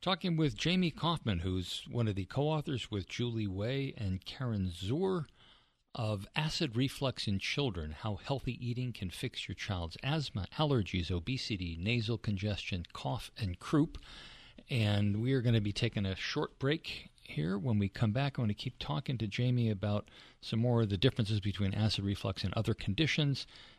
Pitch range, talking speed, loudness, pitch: 100-135 Hz, 175 wpm, -35 LUFS, 115 Hz